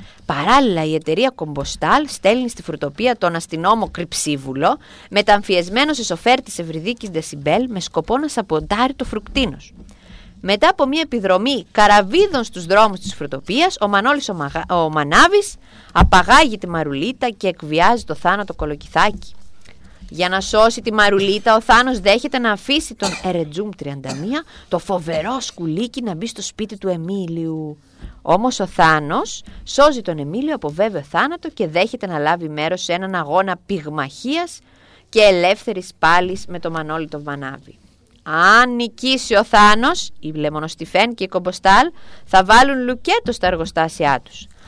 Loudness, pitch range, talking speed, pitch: -17 LUFS, 165-240 Hz, 145 wpm, 195 Hz